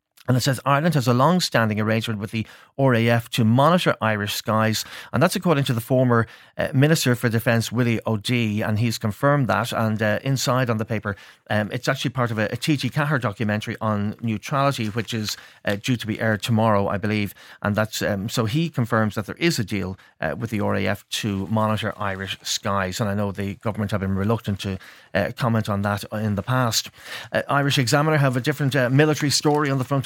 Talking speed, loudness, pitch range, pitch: 210 wpm, -22 LUFS, 105-130 Hz, 115 Hz